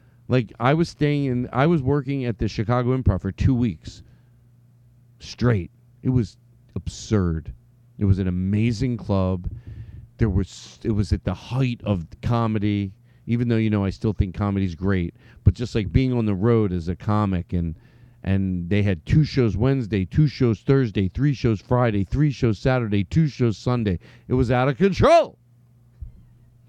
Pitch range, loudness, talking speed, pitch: 100-125 Hz, -22 LUFS, 170 wpm, 115 Hz